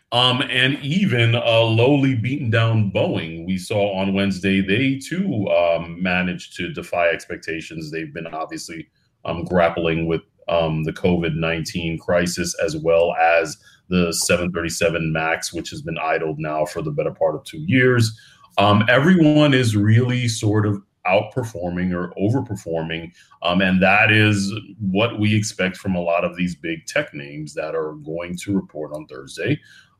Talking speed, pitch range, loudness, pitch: 160 wpm, 85-110 Hz, -20 LUFS, 95 Hz